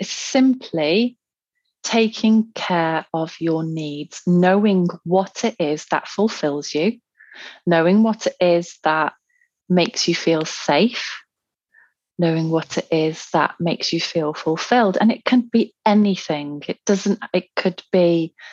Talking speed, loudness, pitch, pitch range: 135 wpm, -19 LUFS, 180 Hz, 160-220 Hz